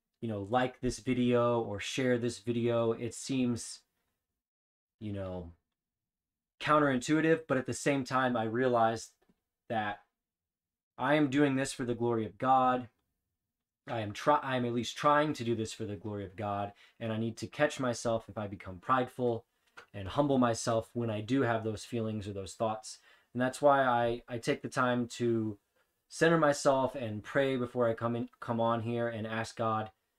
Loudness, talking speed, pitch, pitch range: -32 LUFS, 185 wpm, 120 Hz, 110-130 Hz